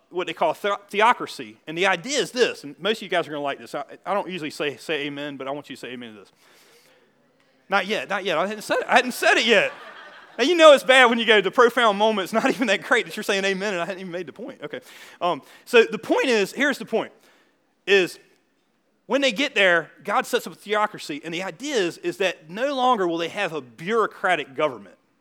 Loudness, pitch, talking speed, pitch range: -21 LUFS, 205 Hz, 260 wpm, 170-245 Hz